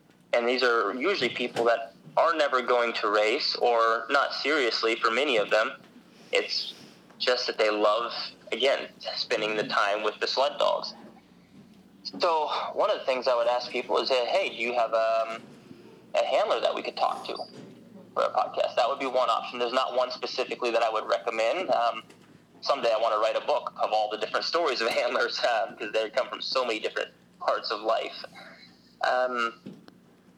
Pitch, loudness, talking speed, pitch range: 120 Hz, -27 LUFS, 190 wpm, 110-125 Hz